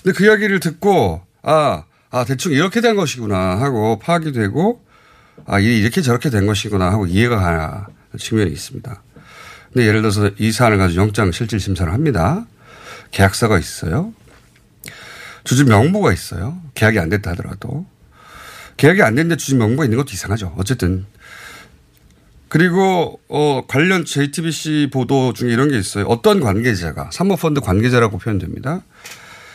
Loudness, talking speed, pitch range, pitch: -16 LUFS, 340 characters per minute, 100-150 Hz, 120 Hz